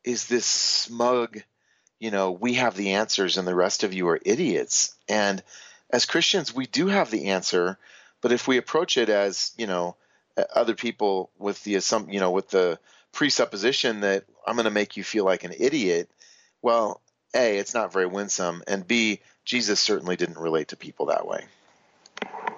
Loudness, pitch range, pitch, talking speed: -24 LUFS, 95-120 Hz, 100 Hz, 180 wpm